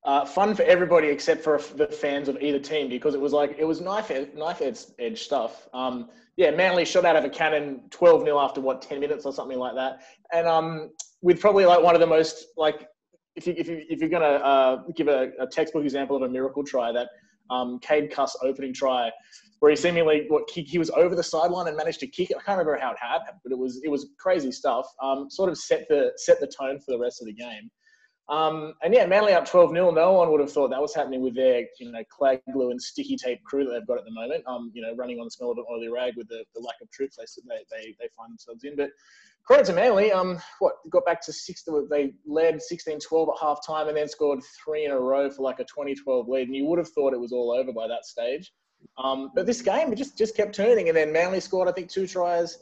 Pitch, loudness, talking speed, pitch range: 155 Hz, -24 LUFS, 260 wpm, 135-180 Hz